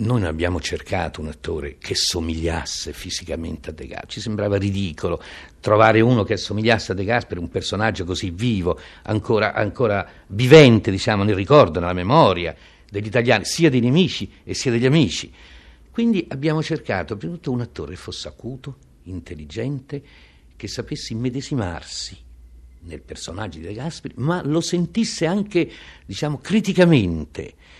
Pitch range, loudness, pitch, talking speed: 85-135 Hz, -20 LUFS, 105 Hz, 150 wpm